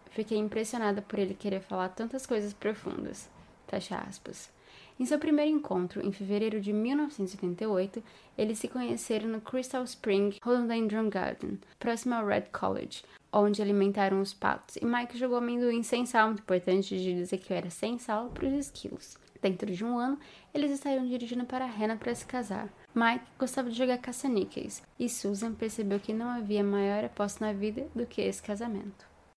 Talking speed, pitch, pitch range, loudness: 175 wpm, 220 Hz, 200-245 Hz, -32 LUFS